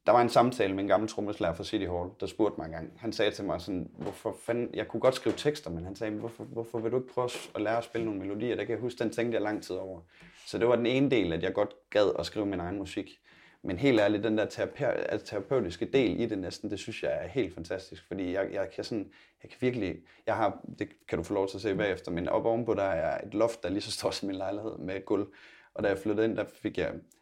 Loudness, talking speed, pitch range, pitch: -31 LUFS, 280 wpm, 95-115 Hz, 110 Hz